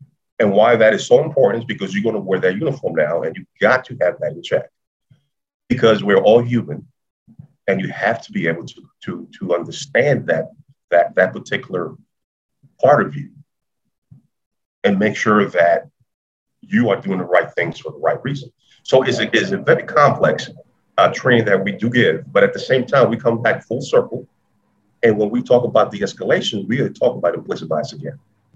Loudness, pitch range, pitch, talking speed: -17 LUFS, 110-145 Hz, 125 Hz, 200 wpm